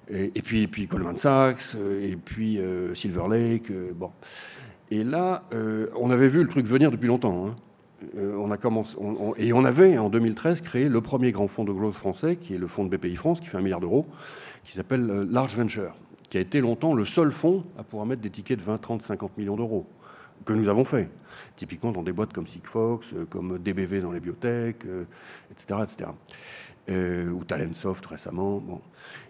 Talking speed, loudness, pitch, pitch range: 210 wpm, -26 LUFS, 110 Hz, 100-125 Hz